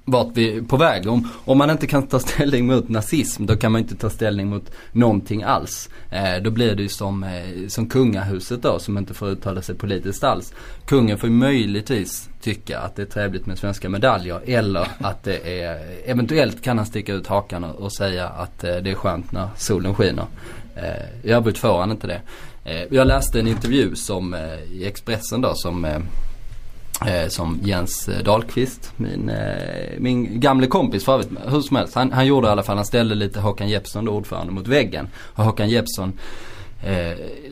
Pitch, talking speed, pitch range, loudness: 105 Hz, 195 wpm, 95-120 Hz, -21 LUFS